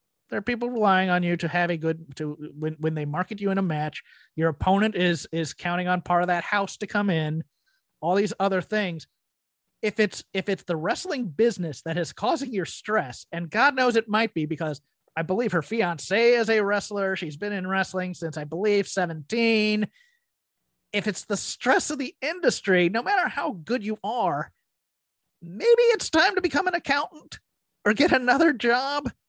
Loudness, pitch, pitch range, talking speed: -25 LUFS, 195 Hz, 170-235 Hz, 195 wpm